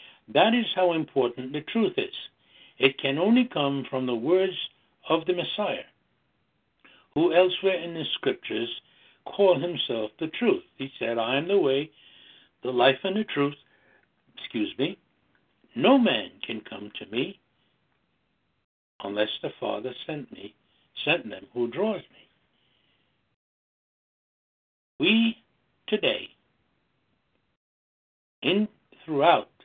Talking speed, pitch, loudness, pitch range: 120 wpm, 170 Hz, -26 LUFS, 135-200 Hz